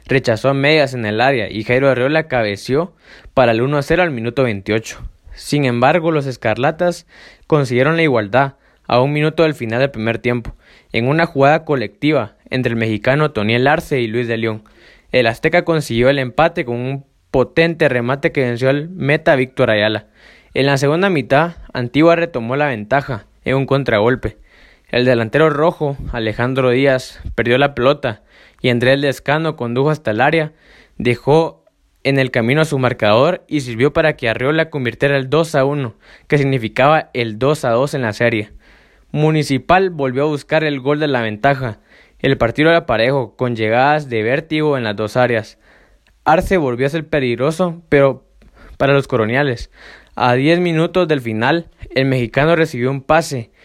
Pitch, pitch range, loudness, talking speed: 135 Hz, 120-150 Hz, -16 LUFS, 165 wpm